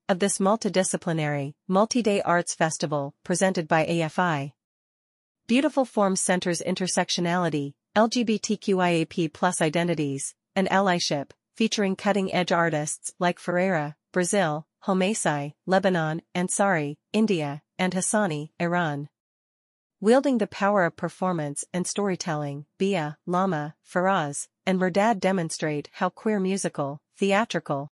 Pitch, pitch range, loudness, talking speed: 180 Hz, 155-195 Hz, -25 LUFS, 105 wpm